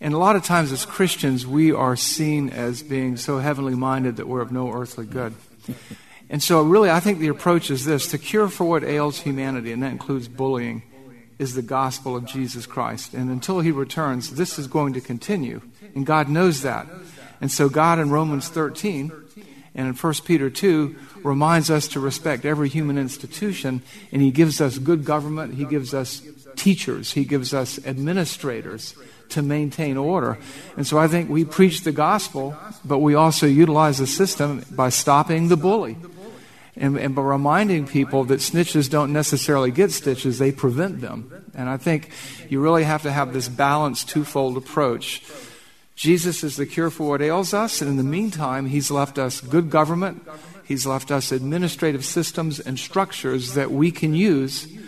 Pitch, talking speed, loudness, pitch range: 145 Hz, 180 wpm, -21 LUFS, 135-165 Hz